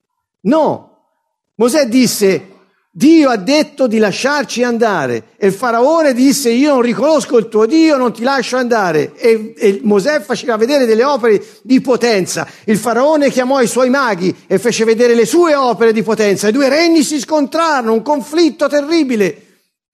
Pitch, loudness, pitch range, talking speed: 245 Hz, -12 LUFS, 220-290 Hz, 160 wpm